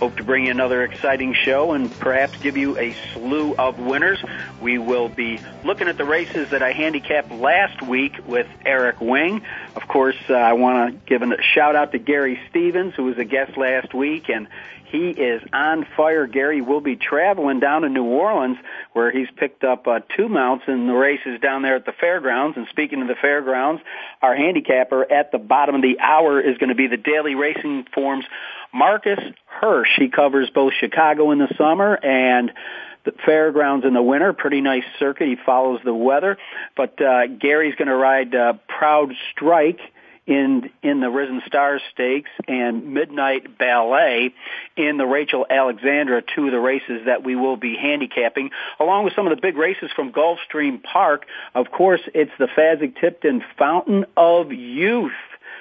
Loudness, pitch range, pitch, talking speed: -19 LUFS, 130-150 Hz, 135 Hz, 180 wpm